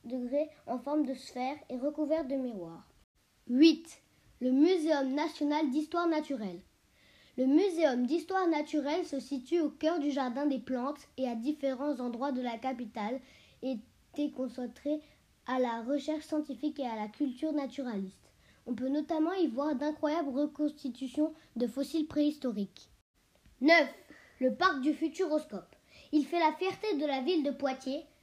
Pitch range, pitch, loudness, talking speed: 260-310 Hz, 290 Hz, -32 LUFS, 145 wpm